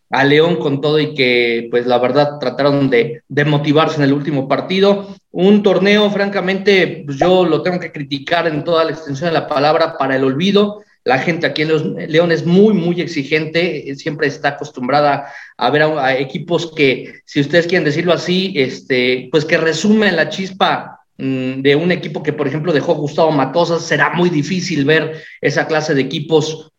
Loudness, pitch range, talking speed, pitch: -15 LUFS, 145-175 Hz, 185 wpm, 155 Hz